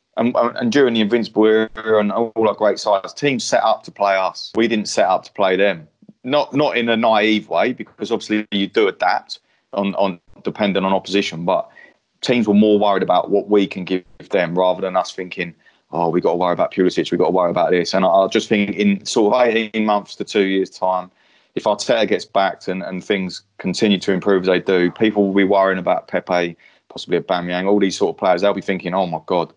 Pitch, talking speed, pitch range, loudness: 100 Hz, 235 wpm, 95-110 Hz, -18 LUFS